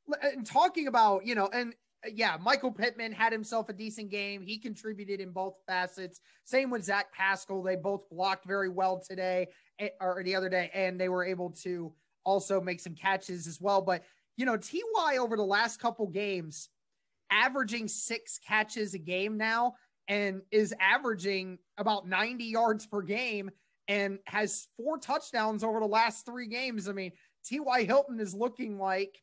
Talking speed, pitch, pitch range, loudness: 170 wpm, 205 Hz, 190-230 Hz, -31 LUFS